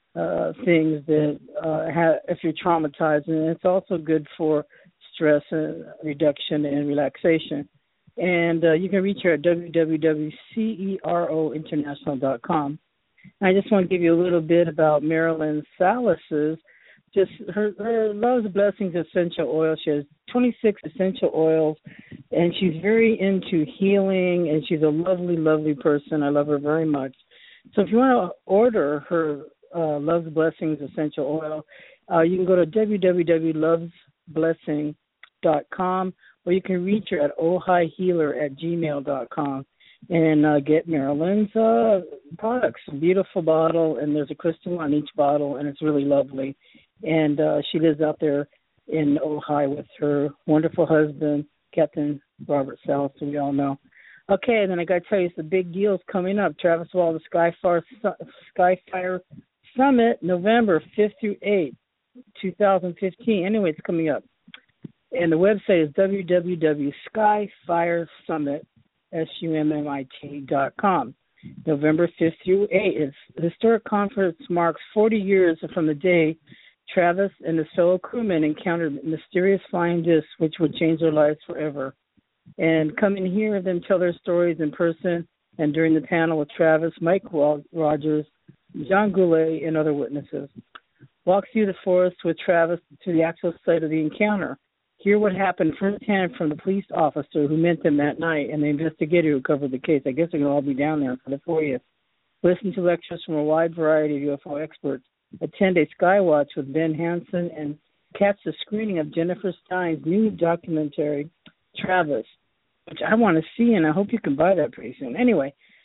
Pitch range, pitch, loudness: 150-185 Hz, 165 Hz, -22 LUFS